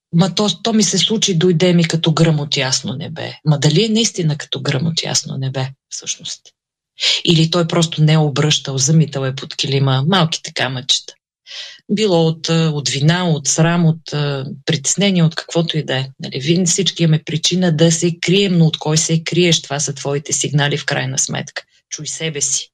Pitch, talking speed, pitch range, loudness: 160 Hz, 195 wpm, 145-175 Hz, -16 LUFS